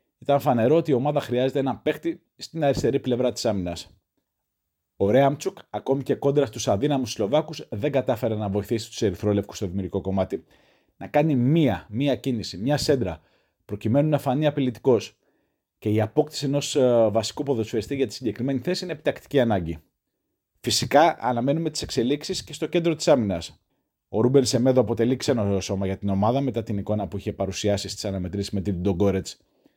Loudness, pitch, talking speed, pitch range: -24 LUFS, 125 Hz, 165 wpm, 100-140 Hz